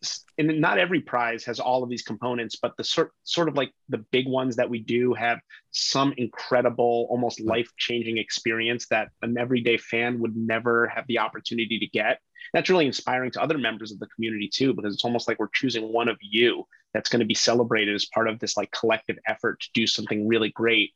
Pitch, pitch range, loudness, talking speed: 120 Hz, 110-125 Hz, -25 LUFS, 215 wpm